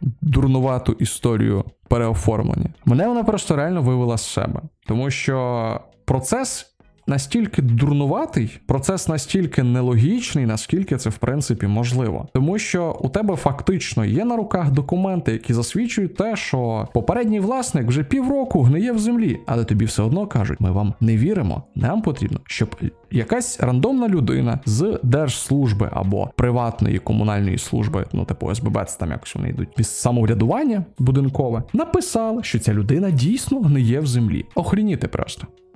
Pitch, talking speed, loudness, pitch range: 130 Hz, 145 wpm, -20 LUFS, 115-180 Hz